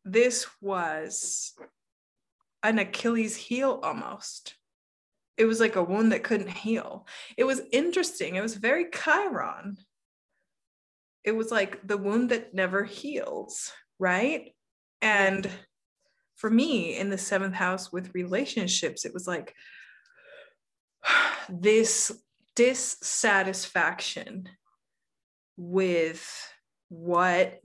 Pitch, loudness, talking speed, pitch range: 210 Hz, -27 LUFS, 100 wpm, 190-240 Hz